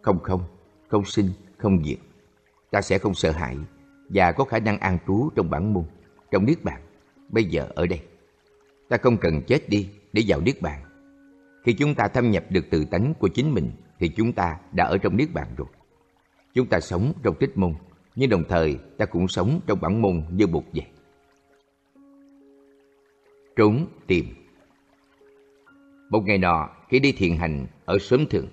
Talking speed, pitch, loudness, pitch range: 180 wpm, 105 Hz, -23 LUFS, 90-140 Hz